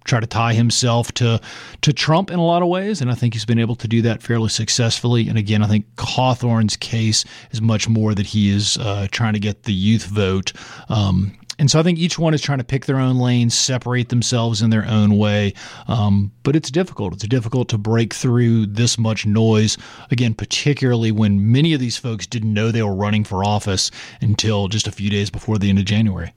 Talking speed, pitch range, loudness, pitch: 225 wpm, 105-125 Hz, -18 LUFS, 115 Hz